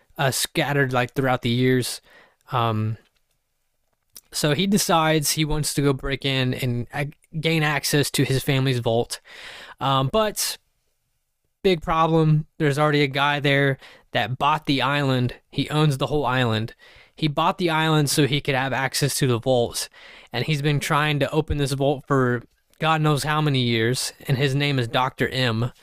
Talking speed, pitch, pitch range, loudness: 170 wpm, 140 Hz, 130-150 Hz, -22 LUFS